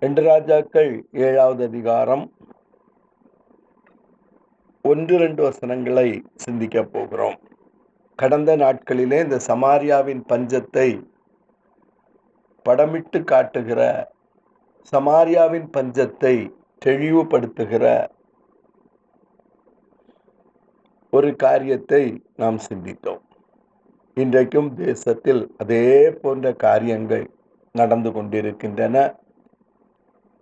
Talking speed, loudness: 60 wpm, -19 LUFS